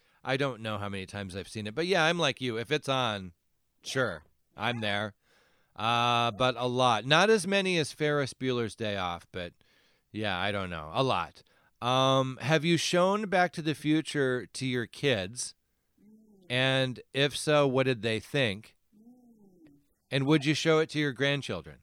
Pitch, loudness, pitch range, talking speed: 130 Hz, -29 LUFS, 110-155 Hz, 180 wpm